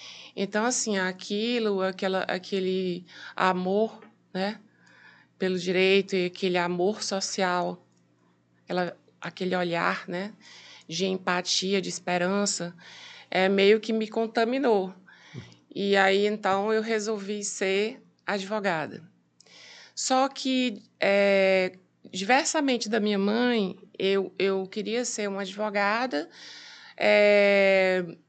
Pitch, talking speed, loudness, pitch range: 195 Hz, 100 wpm, -26 LUFS, 185-215 Hz